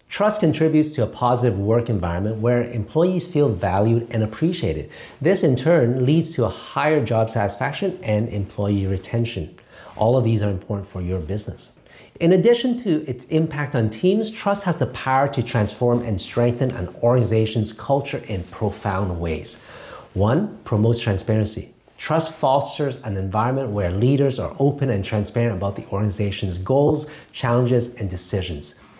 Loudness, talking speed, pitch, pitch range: -21 LUFS, 155 wpm, 120 Hz, 100-140 Hz